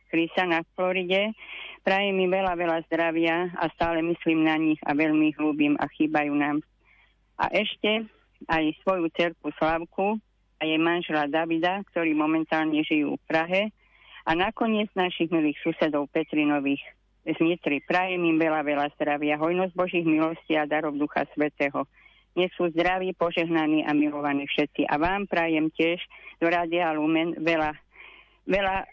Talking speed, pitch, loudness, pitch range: 145 wpm, 165 Hz, -25 LUFS, 155-180 Hz